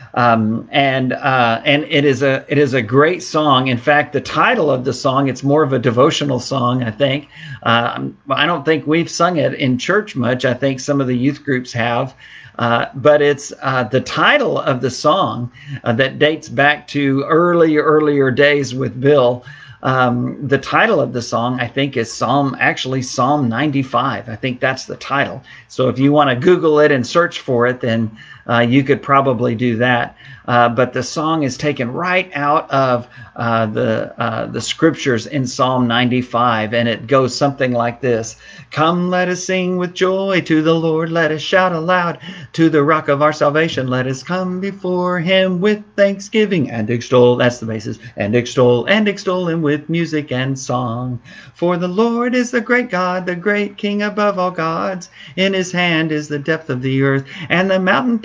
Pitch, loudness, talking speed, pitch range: 140 Hz, -16 LUFS, 195 wpm, 125-165 Hz